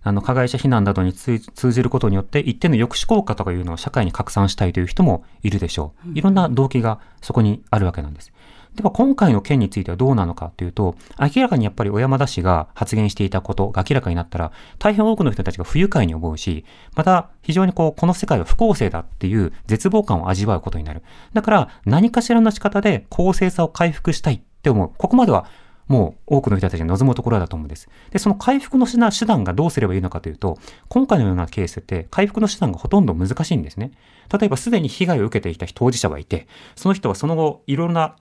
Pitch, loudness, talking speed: 120 Hz, -19 LUFS, 465 characters per minute